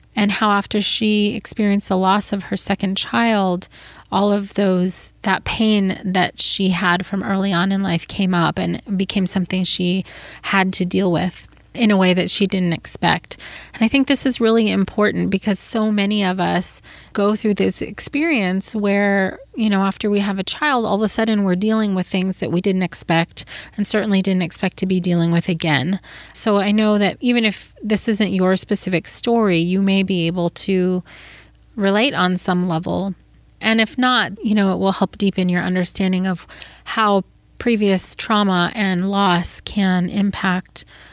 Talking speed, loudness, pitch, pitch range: 180 wpm, -18 LUFS, 195 Hz, 185-210 Hz